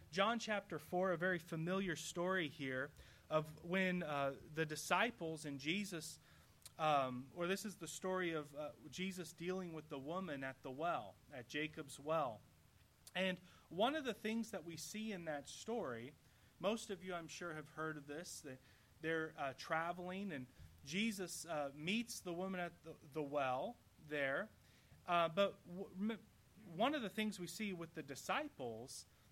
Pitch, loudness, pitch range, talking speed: 170 Hz, -43 LUFS, 150-190 Hz, 165 wpm